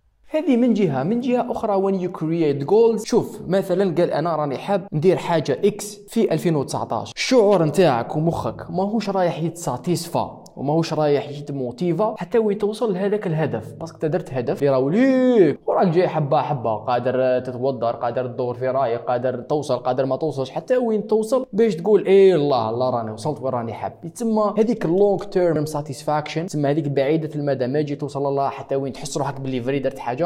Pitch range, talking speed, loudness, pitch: 135-200 Hz, 170 wpm, -21 LUFS, 155 Hz